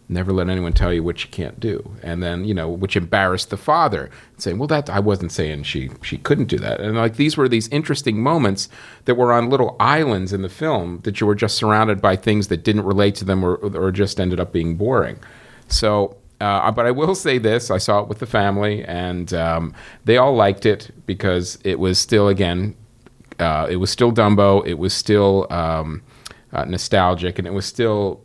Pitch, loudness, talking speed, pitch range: 100 Hz, -19 LUFS, 215 wpm, 90-115 Hz